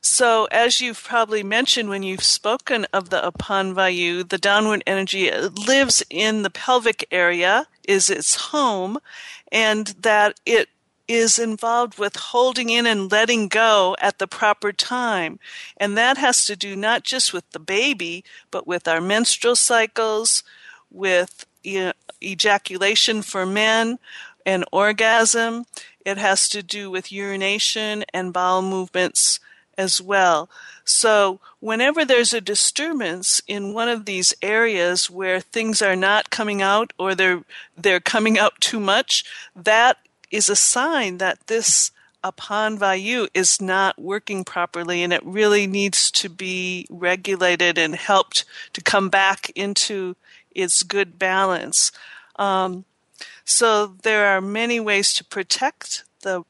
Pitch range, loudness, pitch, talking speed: 190-230 Hz, -19 LUFS, 205 Hz, 140 wpm